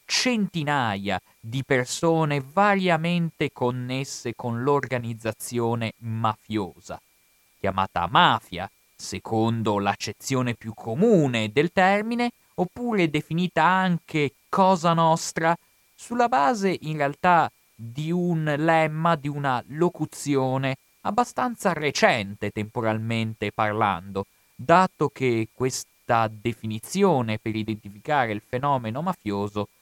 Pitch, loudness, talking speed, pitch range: 135 Hz, -24 LUFS, 90 wpm, 110-170 Hz